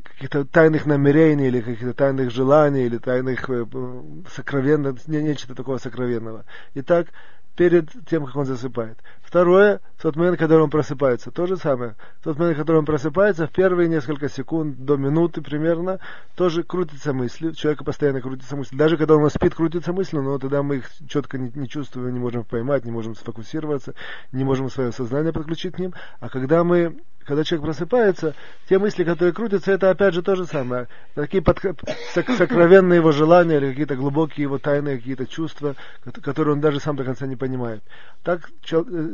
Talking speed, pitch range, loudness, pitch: 180 wpm, 130-170 Hz, -21 LUFS, 150 Hz